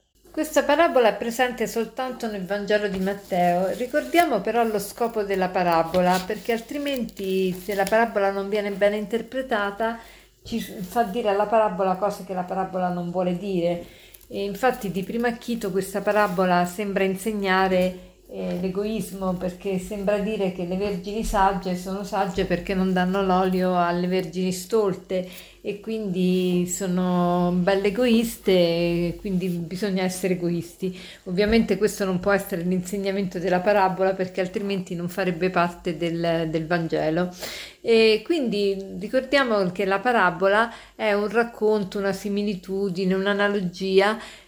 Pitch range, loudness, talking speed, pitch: 185-215 Hz, -24 LUFS, 135 wpm, 195 Hz